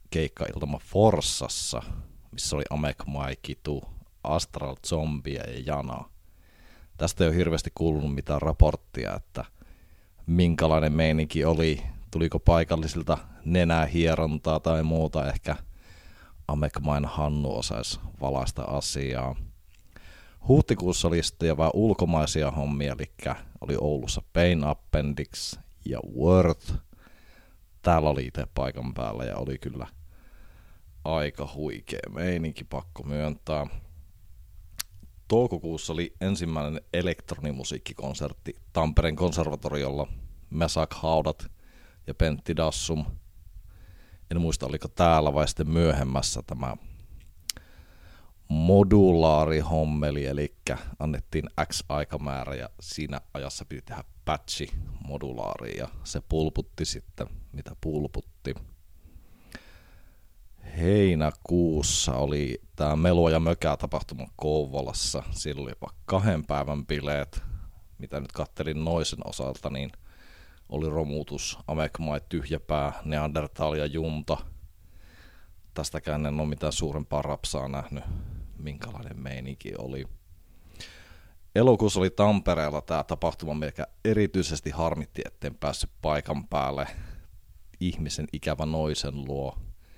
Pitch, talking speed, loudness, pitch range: 80 Hz, 100 wpm, -28 LUFS, 75-85 Hz